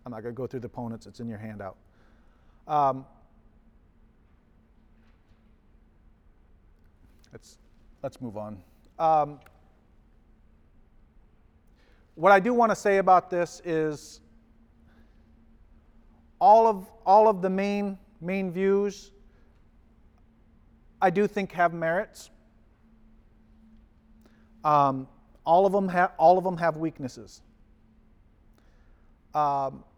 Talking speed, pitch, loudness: 100 wpm, 115 Hz, -25 LUFS